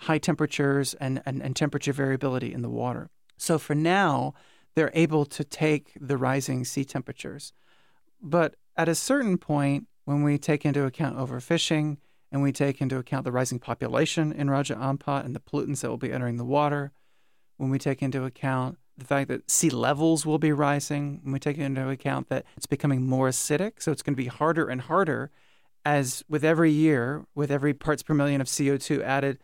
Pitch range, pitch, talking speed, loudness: 135-150 Hz, 145 Hz, 195 wpm, -26 LUFS